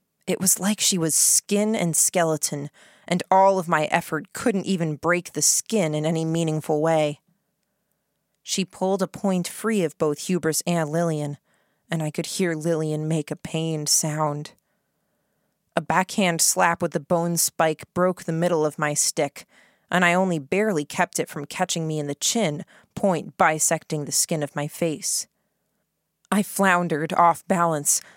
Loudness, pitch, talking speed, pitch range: -22 LUFS, 165 Hz, 165 wpm, 155-185 Hz